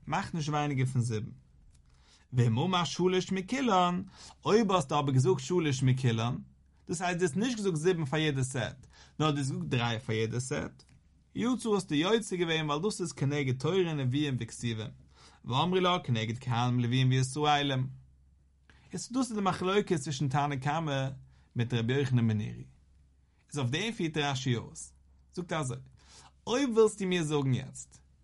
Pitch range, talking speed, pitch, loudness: 115-175 Hz, 185 wpm, 140 Hz, -31 LUFS